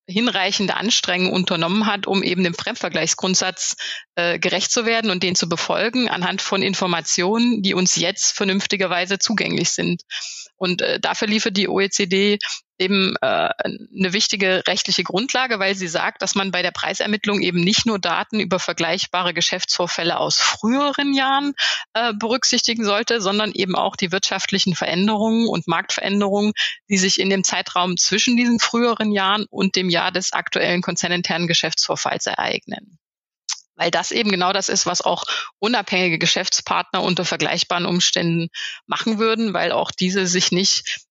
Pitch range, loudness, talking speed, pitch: 180-215 Hz, -19 LUFS, 150 wpm, 195 Hz